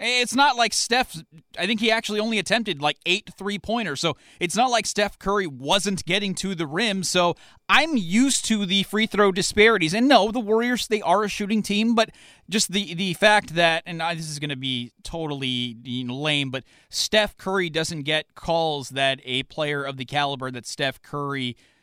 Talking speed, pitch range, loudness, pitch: 205 wpm, 150-215 Hz, -22 LUFS, 180 Hz